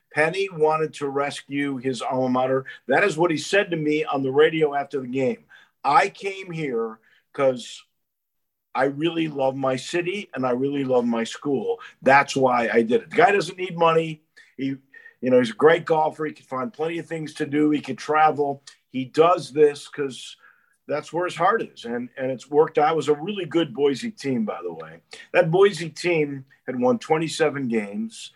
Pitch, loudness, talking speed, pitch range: 150 Hz, -23 LUFS, 200 wpm, 135-170 Hz